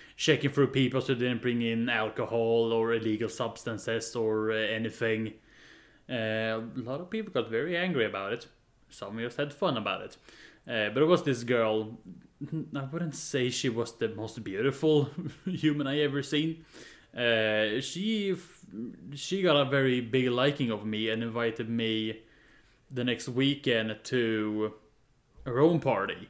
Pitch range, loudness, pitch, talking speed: 110-145 Hz, -30 LUFS, 125 Hz, 160 wpm